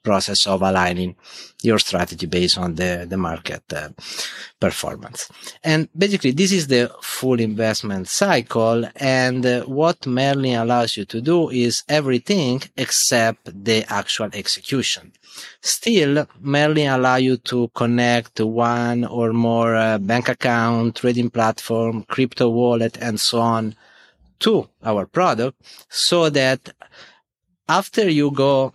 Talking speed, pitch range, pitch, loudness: 125 wpm, 115-135 Hz, 120 Hz, -19 LUFS